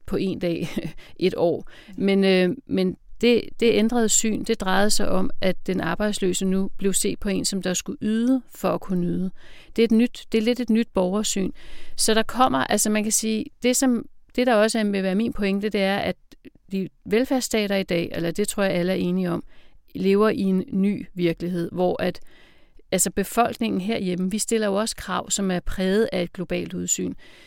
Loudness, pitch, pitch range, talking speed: -23 LUFS, 200 Hz, 185-225 Hz, 210 wpm